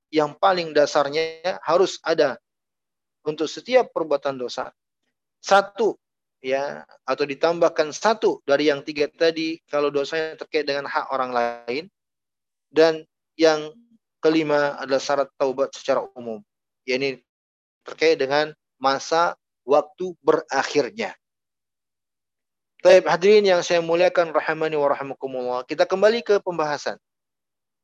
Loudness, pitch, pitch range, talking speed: -22 LUFS, 150 Hz, 140-170 Hz, 110 wpm